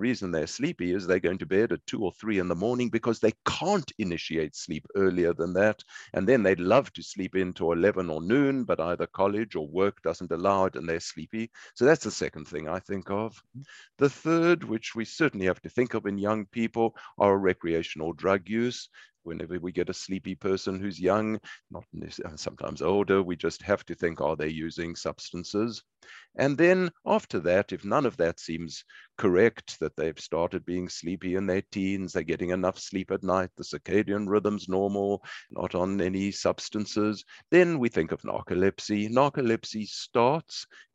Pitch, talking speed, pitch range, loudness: 95 Hz, 185 wpm, 90-110 Hz, -28 LUFS